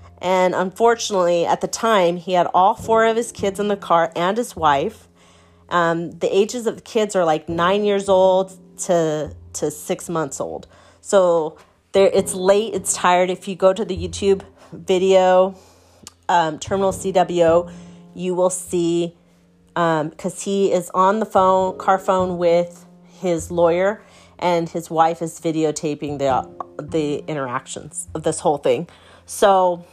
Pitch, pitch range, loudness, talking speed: 180 Hz, 165-195 Hz, -19 LUFS, 155 wpm